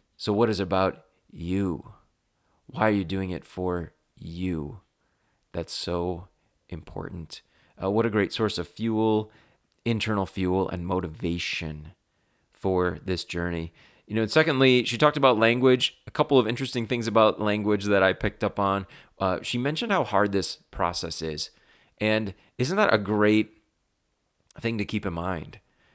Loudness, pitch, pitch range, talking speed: -26 LUFS, 100 Hz, 90-110 Hz, 155 wpm